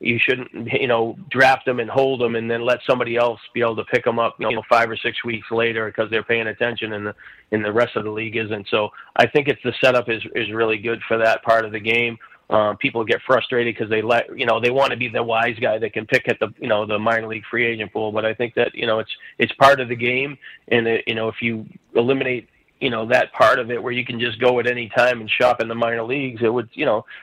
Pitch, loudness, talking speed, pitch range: 115 Hz, -20 LUFS, 280 wpm, 110-120 Hz